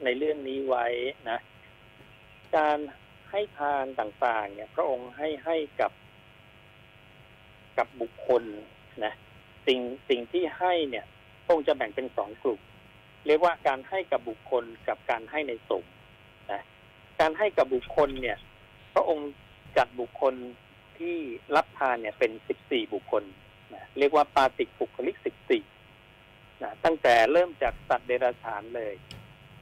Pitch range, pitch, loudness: 110-165 Hz, 130 Hz, -29 LUFS